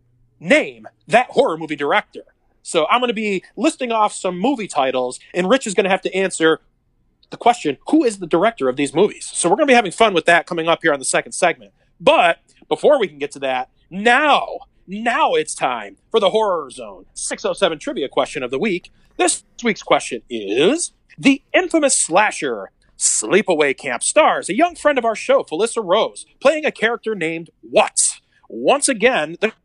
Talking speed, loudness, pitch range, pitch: 190 wpm, -18 LUFS, 160-260 Hz, 210 Hz